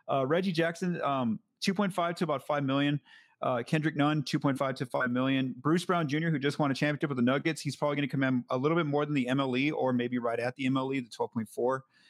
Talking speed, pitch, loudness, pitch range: 235 wpm, 145 Hz, -30 LUFS, 130-160 Hz